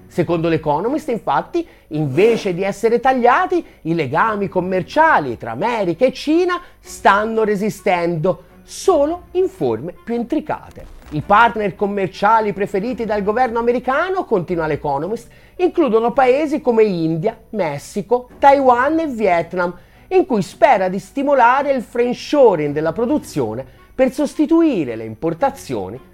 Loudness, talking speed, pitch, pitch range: -17 LUFS, 115 wpm, 225 Hz, 180-275 Hz